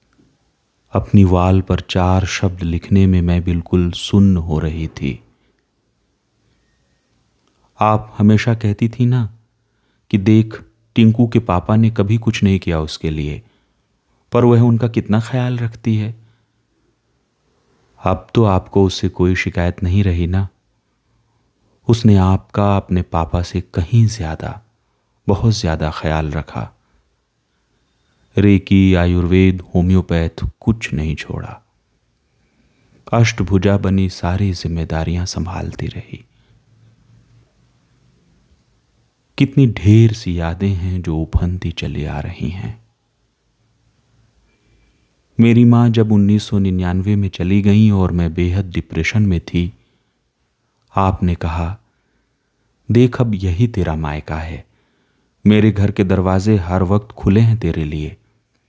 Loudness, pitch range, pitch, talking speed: -16 LUFS, 90-115 Hz, 100 Hz, 115 wpm